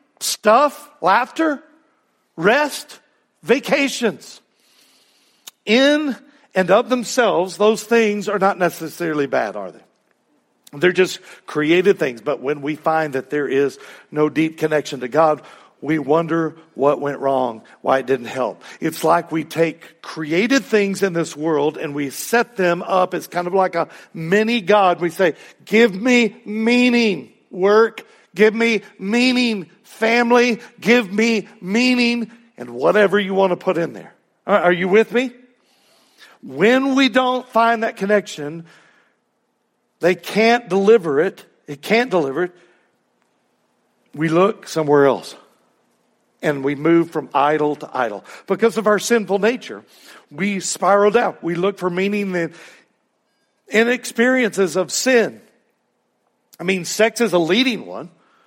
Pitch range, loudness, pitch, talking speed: 160-230 Hz, -18 LUFS, 195 Hz, 140 wpm